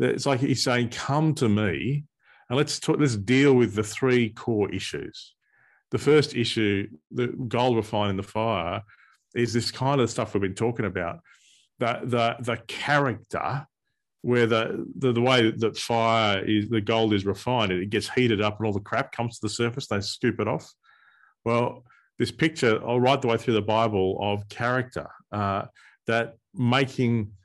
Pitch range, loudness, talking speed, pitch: 105-125 Hz, -25 LUFS, 180 wpm, 115 Hz